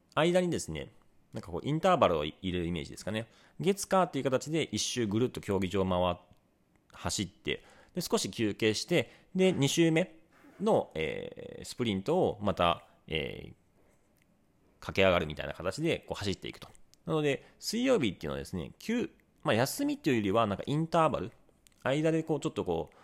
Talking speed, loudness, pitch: 365 characters per minute, -31 LUFS, 125 Hz